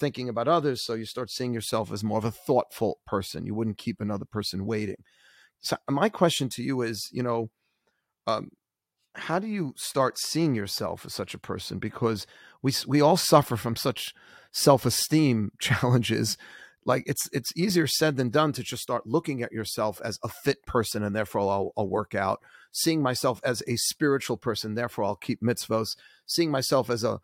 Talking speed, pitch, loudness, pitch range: 190 wpm, 120 Hz, -27 LUFS, 110-140 Hz